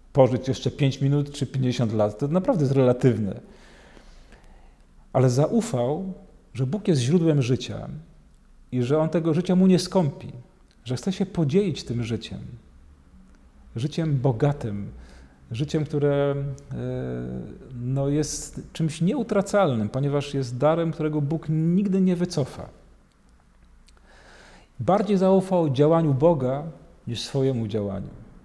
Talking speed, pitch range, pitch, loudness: 115 wpm, 115-160 Hz, 140 Hz, -24 LUFS